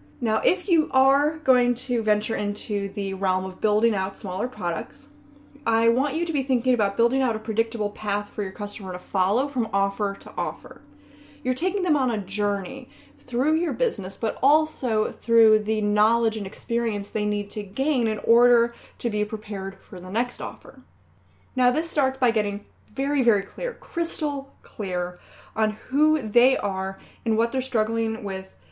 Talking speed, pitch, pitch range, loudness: 175 wpm, 225 Hz, 205-265 Hz, -24 LUFS